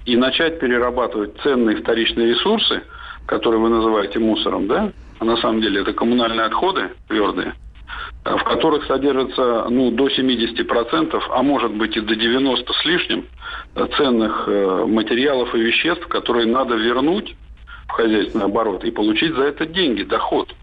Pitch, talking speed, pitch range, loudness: 120 Hz, 140 wpm, 115-130 Hz, -18 LUFS